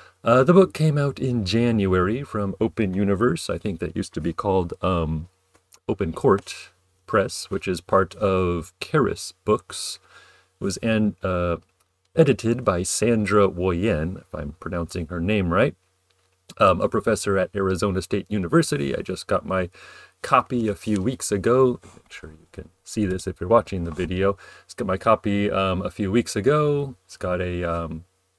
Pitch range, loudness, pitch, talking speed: 90-115 Hz, -23 LUFS, 95 Hz, 175 wpm